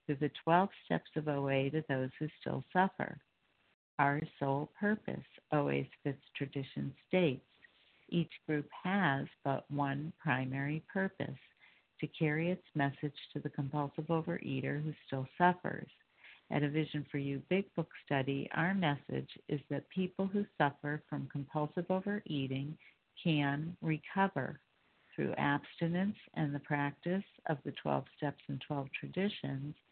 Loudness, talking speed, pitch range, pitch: -37 LUFS, 135 wpm, 140-170 Hz, 150 Hz